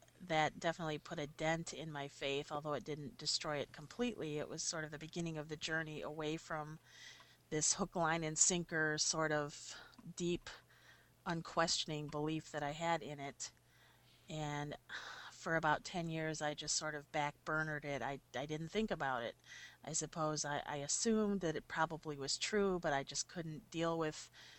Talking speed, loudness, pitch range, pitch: 180 wpm, -40 LUFS, 150-165 Hz, 155 Hz